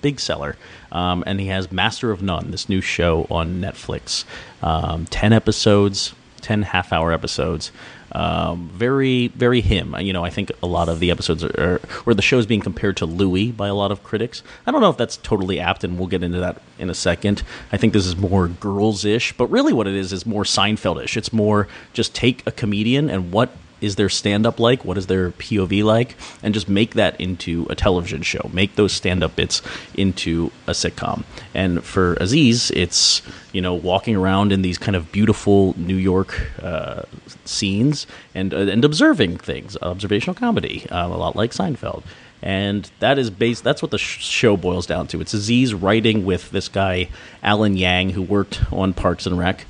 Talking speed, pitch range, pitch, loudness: 205 wpm, 90-110 Hz, 100 Hz, -20 LUFS